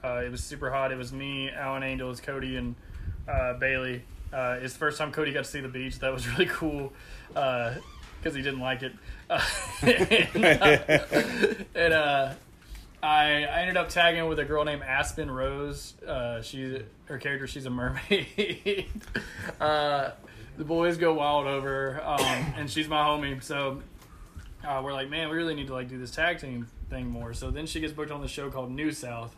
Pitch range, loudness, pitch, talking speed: 125-150 Hz, -28 LUFS, 135 Hz, 195 wpm